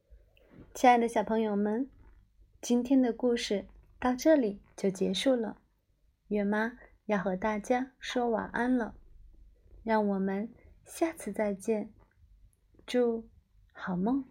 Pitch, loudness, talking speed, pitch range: 220 Hz, -30 LUFS, 165 characters per minute, 195-245 Hz